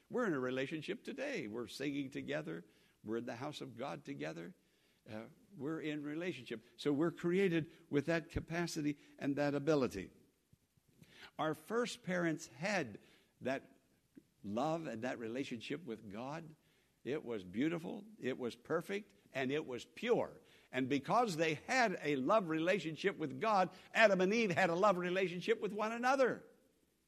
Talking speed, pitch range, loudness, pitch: 150 wpm, 140-190 Hz, -38 LUFS, 160 Hz